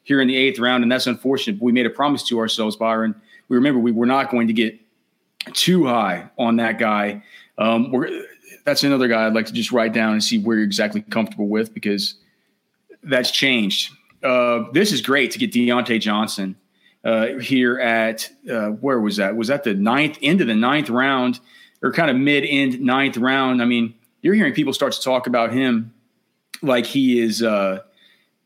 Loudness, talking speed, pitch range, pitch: -19 LUFS, 195 wpm, 110-130 Hz, 120 Hz